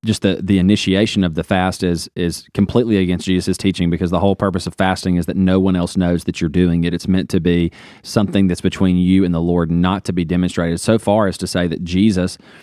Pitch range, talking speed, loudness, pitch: 90-95 Hz, 240 wpm, -17 LUFS, 95 Hz